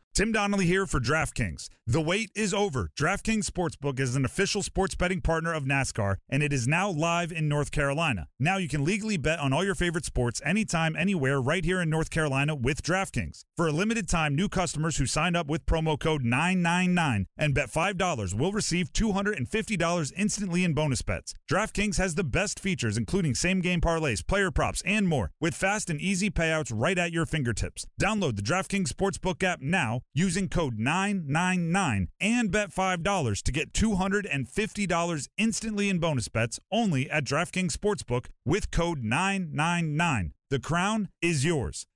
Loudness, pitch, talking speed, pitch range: -27 LUFS, 170 Hz, 175 wpm, 140-190 Hz